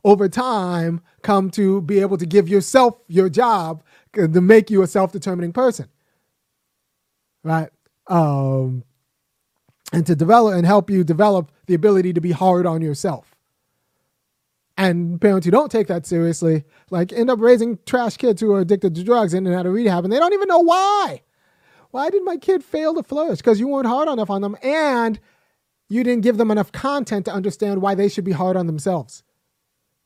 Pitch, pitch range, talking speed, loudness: 200 Hz, 175-235 Hz, 180 wpm, -18 LUFS